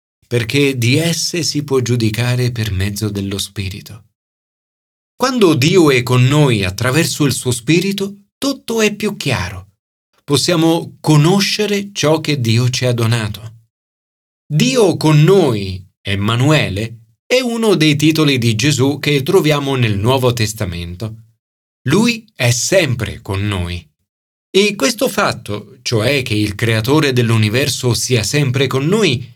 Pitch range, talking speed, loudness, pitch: 110-155 Hz, 130 wpm, -15 LUFS, 125 Hz